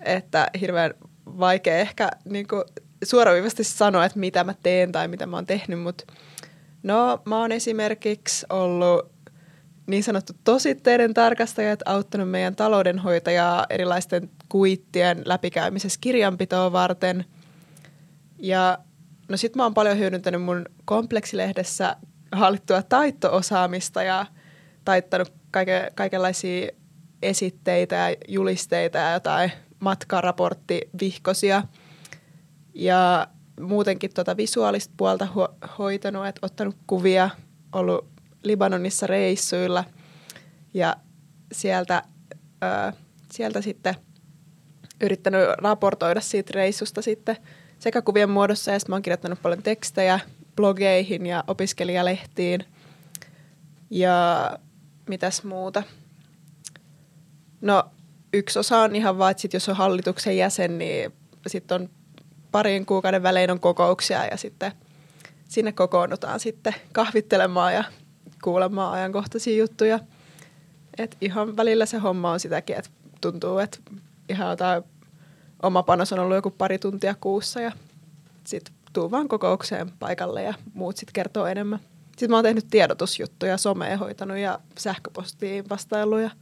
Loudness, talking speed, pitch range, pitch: -23 LUFS, 115 wpm, 165-200 Hz, 185 Hz